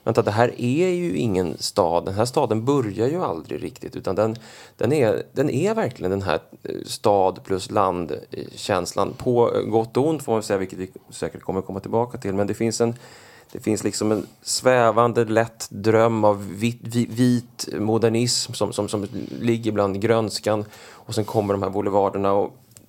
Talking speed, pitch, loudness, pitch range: 185 wpm, 110 Hz, -22 LUFS, 100-115 Hz